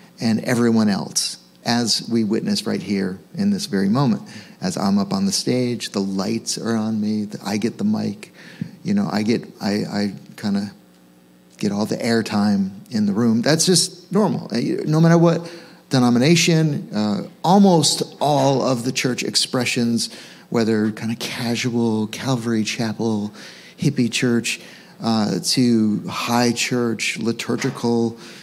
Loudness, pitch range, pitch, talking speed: -20 LUFS, 110-175 Hz, 120 Hz, 145 wpm